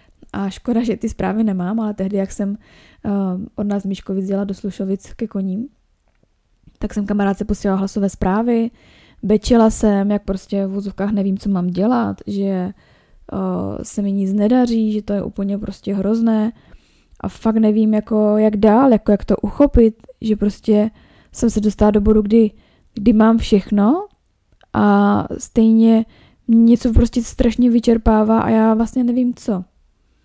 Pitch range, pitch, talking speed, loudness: 200-225 Hz, 210 Hz, 155 wpm, -17 LUFS